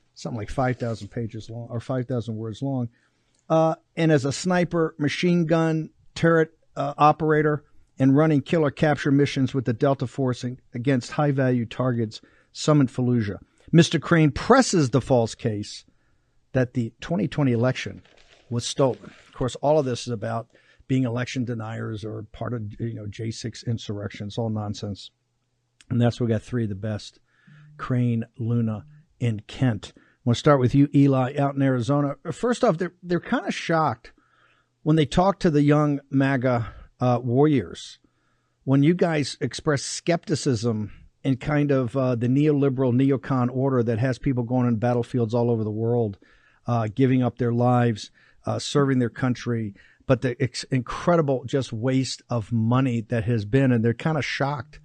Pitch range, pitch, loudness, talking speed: 120-145 Hz, 130 Hz, -24 LUFS, 170 wpm